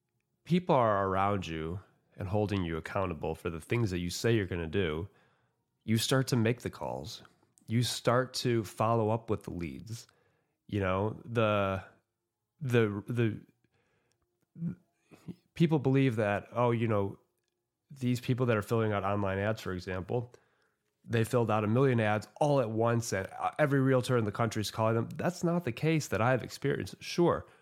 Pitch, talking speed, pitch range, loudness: 115 Hz, 175 wpm, 100-125 Hz, -31 LUFS